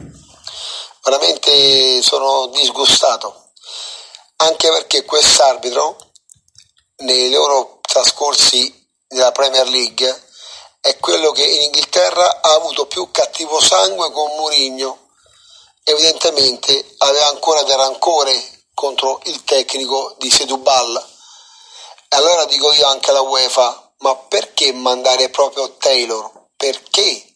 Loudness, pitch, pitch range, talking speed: -13 LUFS, 135 Hz, 130-155 Hz, 100 wpm